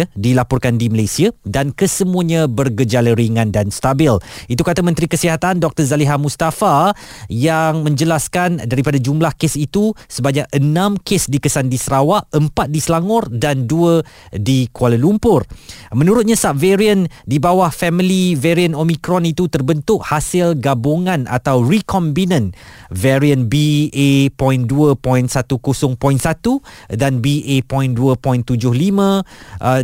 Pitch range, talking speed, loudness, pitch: 130-170 Hz, 110 wpm, -15 LUFS, 145 Hz